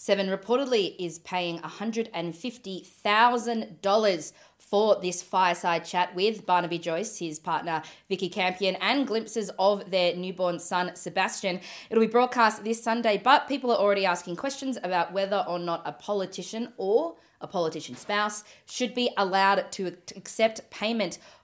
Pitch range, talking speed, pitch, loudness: 180-225 Hz, 140 wpm, 195 Hz, -27 LUFS